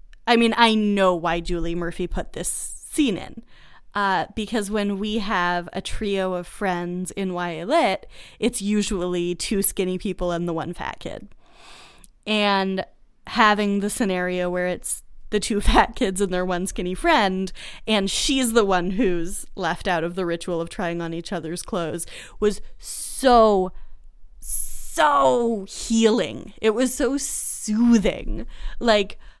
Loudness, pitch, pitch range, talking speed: -22 LUFS, 195 Hz, 180-220 Hz, 145 wpm